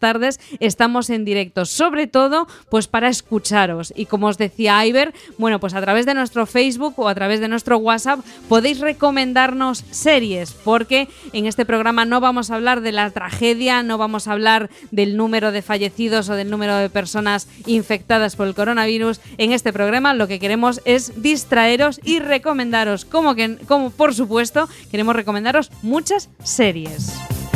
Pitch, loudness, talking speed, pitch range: 230 Hz, -18 LUFS, 170 wpm, 210-260 Hz